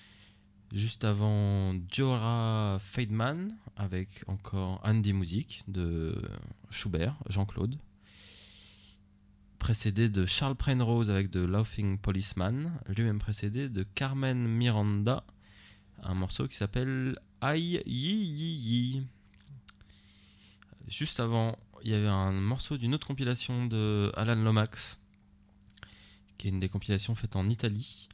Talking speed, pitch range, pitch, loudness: 115 wpm, 100-120 Hz, 105 Hz, -32 LUFS